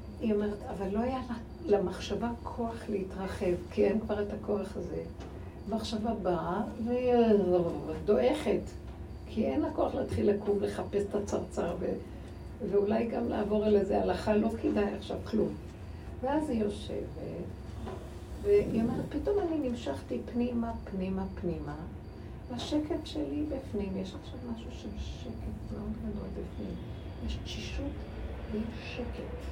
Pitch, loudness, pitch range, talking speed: 205 Hz, -33 LUFS, 185-240 Hz, 130 wpm